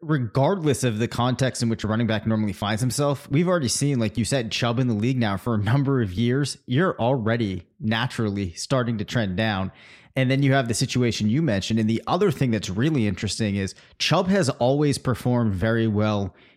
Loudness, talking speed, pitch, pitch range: -23 LUFS, 205 wpm, 120 Hz, 110-135 Hz